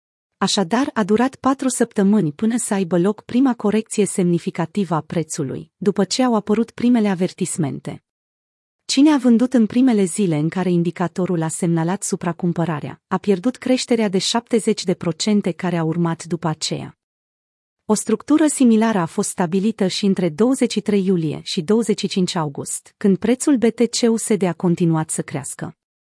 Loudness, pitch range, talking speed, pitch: -19 LUFS, 170-225 Hz, 140 wpm, 195 Hz